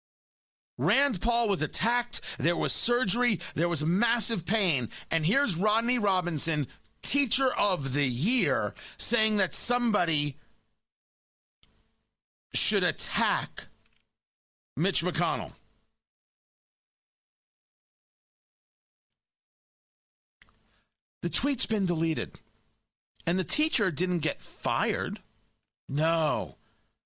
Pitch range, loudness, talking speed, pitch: 155-230 Hz, -27 LUFS, 80 wpm, 180 Hz